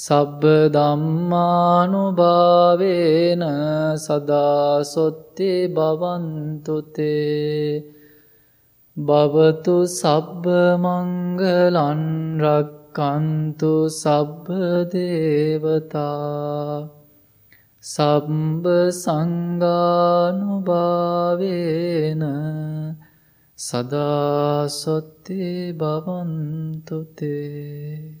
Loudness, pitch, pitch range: -20 LUFS, 155 Hz, 150-175 Hz